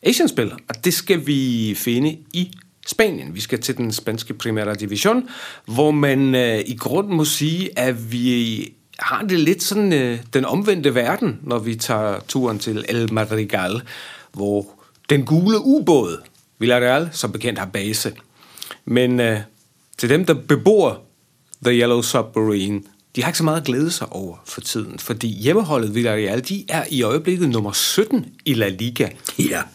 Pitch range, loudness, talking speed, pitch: 110-160 Hz, -19 LUFS, 165 wpm, 125 Hz